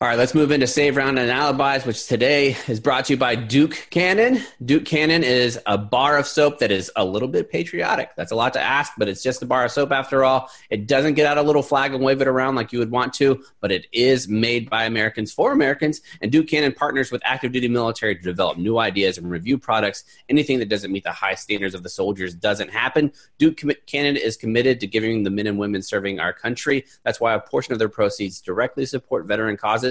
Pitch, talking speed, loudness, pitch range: 125 Hz, 245 wpm, -20 LUFS, 110-140 Hz